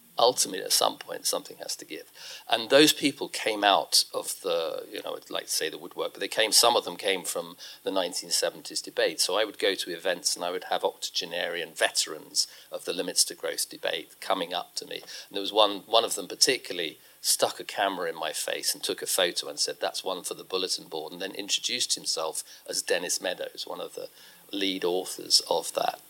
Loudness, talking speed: -27 LUFS, 220 wpm